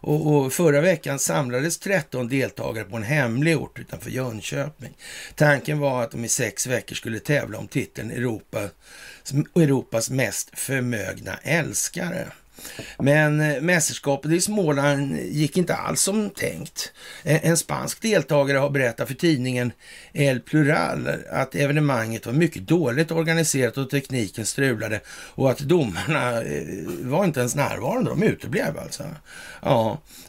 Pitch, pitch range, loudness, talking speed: 140 Hz, 125-160 Hz, -23 LUFS, 130 wpm